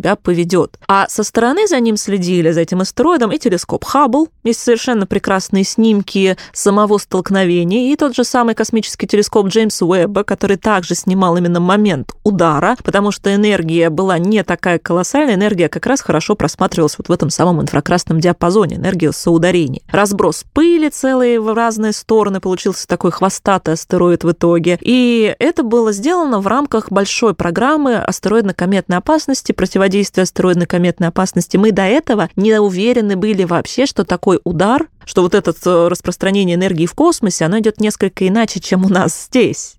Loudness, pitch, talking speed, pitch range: -14 LUFS, 195 Hz, 160 wpm, 180-225 Hz